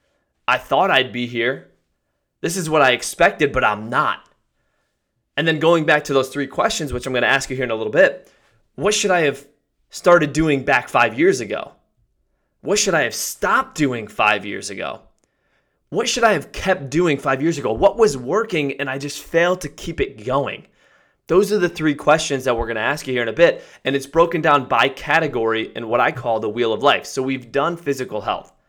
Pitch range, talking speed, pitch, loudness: 130-170 Hz, 220 wpm, 145 Hz, -19 LUFS